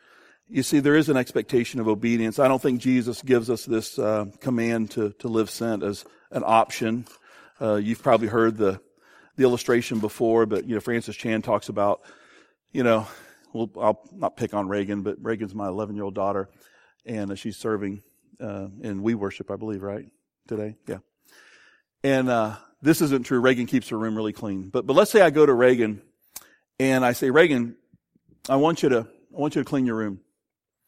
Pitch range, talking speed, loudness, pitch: 105-125 Hz, 195 wpm, -24 LUFS, 115 Hz